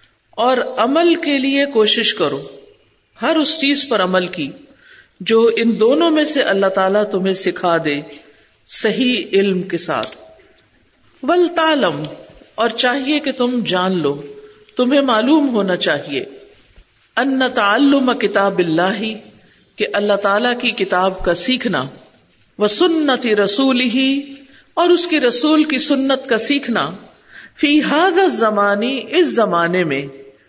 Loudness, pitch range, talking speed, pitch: -16 LUFS, 195-280 Hz, 130 wpm, 235 Hz